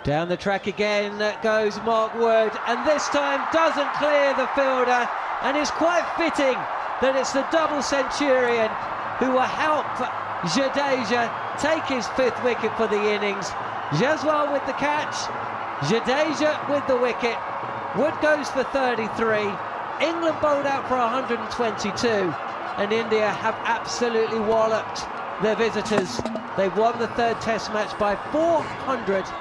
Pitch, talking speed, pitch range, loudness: 235 Hz, 135 wpm, 215-275 Hz, -23 LUFS